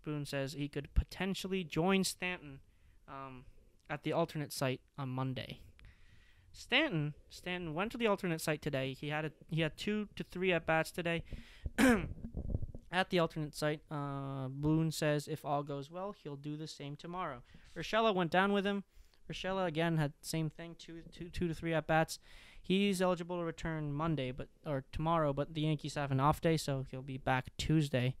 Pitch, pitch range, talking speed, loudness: 155 Hz, 140-170 Hz, 185 wpm, -36 LUFS